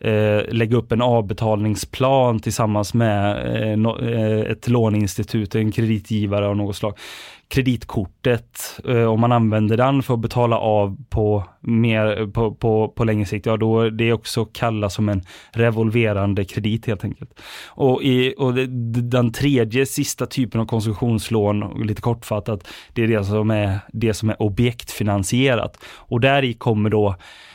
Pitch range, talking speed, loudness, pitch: 105-120 Hz, 145 wpm, -20 LUFS, 110 Hz